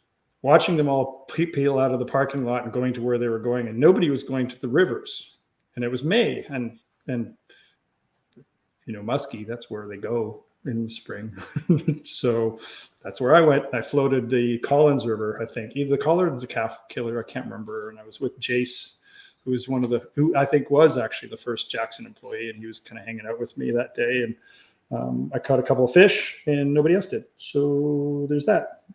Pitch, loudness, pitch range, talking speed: 125 Hz, -23 LUFS, 115-145 Hz, 220 wpm